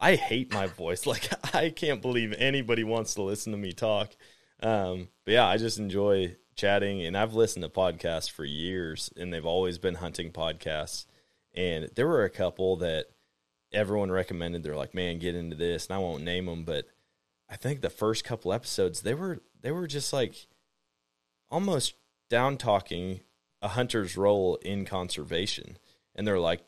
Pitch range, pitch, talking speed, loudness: 80-105 Hz, 95 Hz, 175 wpm, -30 LUFS